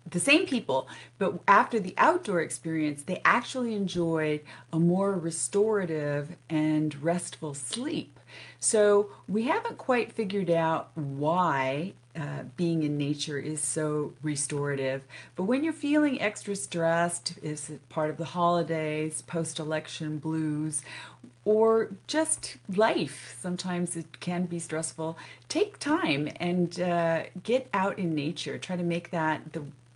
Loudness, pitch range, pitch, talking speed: -29 LUFS, 155-200 Hz, 165 Hz, 135 wpm